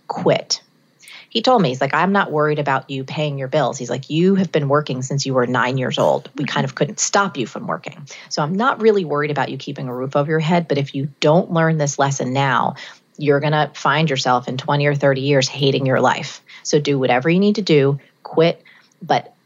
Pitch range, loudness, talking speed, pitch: 135-160 Hz, -18 LUFS, 235 wpm, 145 Hz